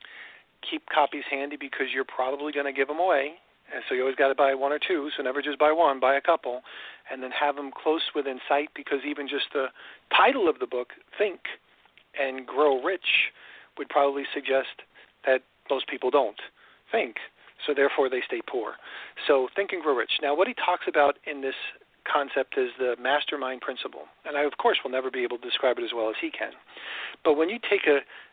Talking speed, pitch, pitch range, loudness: 210 wpm, 140 Hz, 130-150 Hz, -26 LUFS